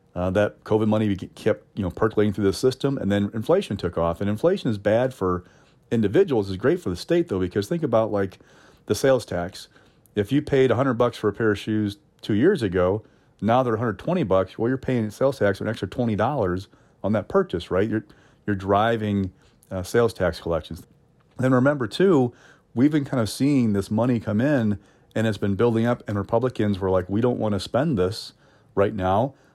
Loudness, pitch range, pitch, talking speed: -23 LUFS, 100-125 Hz, 110 Hz, 205 wpm